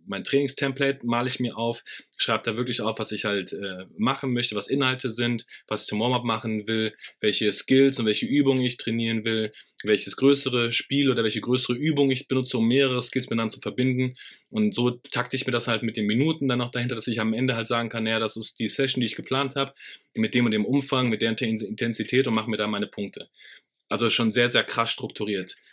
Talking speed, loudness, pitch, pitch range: 225 wpm, -24 LUFS, 120 Hz, 110-130 Hz